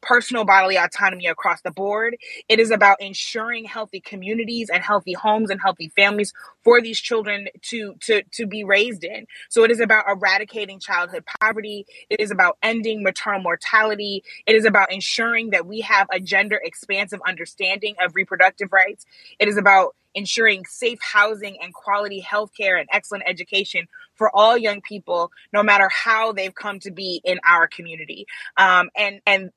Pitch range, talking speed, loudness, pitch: 190-220 Hz, 170 wpm, -19 LUFS, 205 Hz